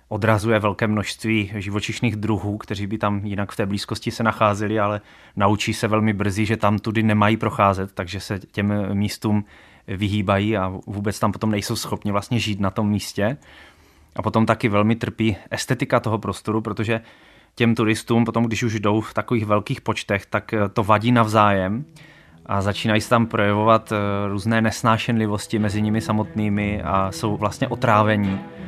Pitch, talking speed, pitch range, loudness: 105 Hz, 160 wpm, 105-115 Hz, -21 LUFS